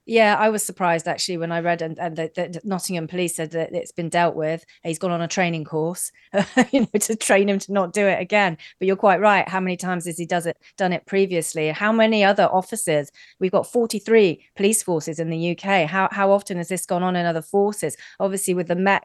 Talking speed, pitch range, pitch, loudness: 235 wpm, 170-200 Hz, 185 Hz, -21 LUFS